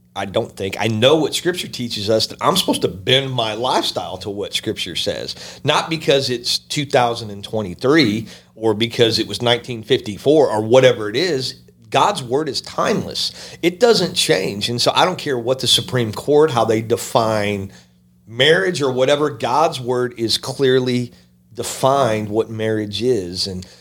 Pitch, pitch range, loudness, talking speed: 115 Hz, 105-130 Hz, -18 LUFS, 170 wpm